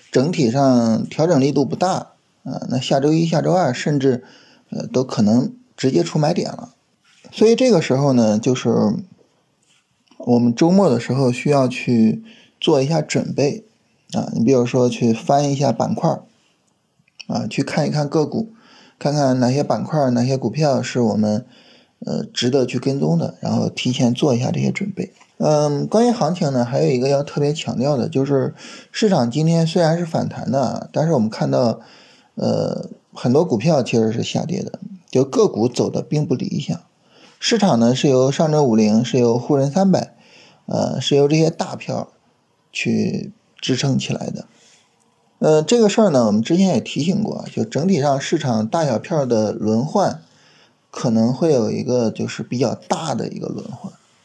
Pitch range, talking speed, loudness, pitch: 125-165 Hz, 250 characters per minute, -18 LUFS, 140 Hz